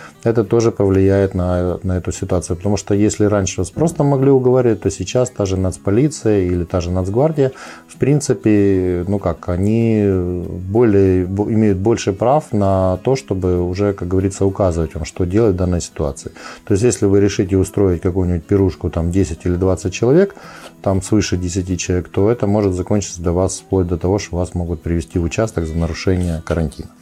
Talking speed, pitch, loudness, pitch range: 180 wpm, 95 Hz, -17 LUFS, 90-105 Hz